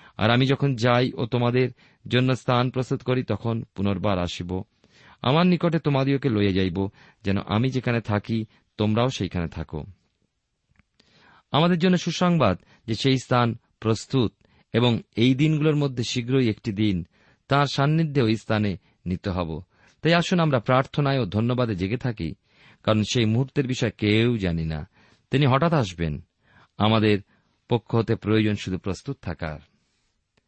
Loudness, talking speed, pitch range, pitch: -24 LUFS, 130 wpm, 100-135 Hz, 115 Hz